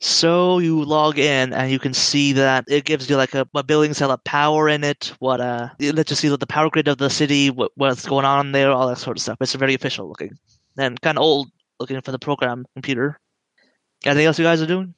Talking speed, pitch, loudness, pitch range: 250 wpm, 140 Hz, -19 LUFS, 130-150 Hz